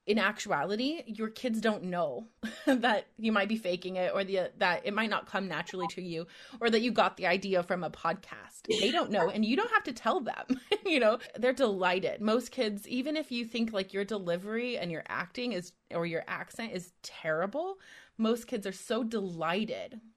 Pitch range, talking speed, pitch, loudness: 185-245 Hz, 200 wpm, 220 Hz, -32 LUFS